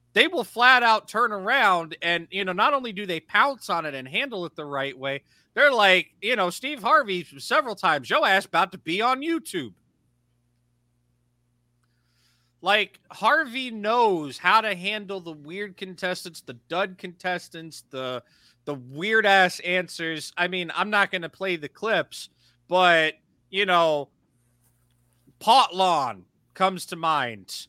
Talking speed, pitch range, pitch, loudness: 155 wpm, 135-200 Hz, 175 Hz, -23 LUFS